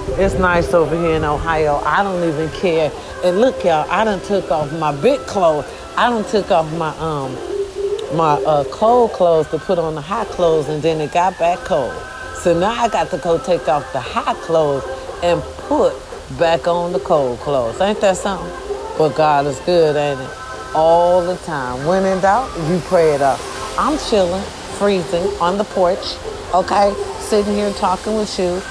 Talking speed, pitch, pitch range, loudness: 190 wpm, 175 Hz, 160-195 Hz, -17 LUFS